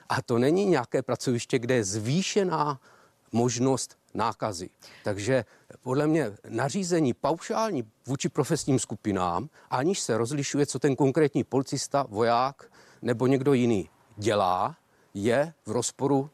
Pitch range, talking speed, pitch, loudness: 120-145 Hz, 120 wpm, 135 Hz, -27 LUFS